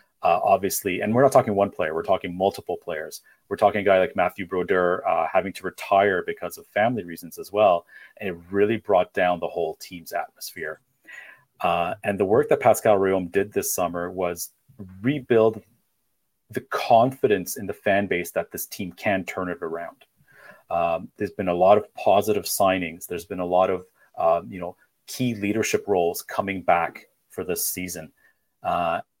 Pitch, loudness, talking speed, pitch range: 95 Hz, -23 LUFS, 180 wpm, 90-105 Hz